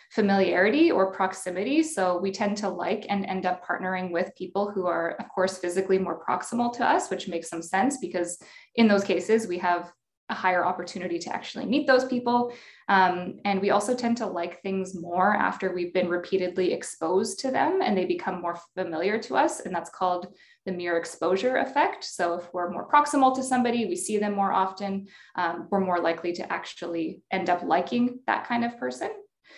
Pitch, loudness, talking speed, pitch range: 190 Hz, -26 LUFS, 195 wpm, 175-215 Hz